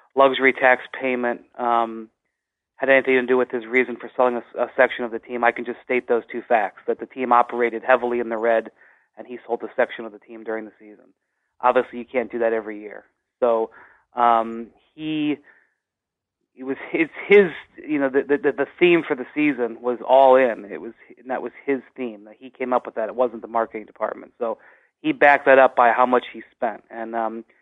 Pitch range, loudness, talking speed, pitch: 115-130 Hz, -21 LUFS, 220 wpm, 125 Hz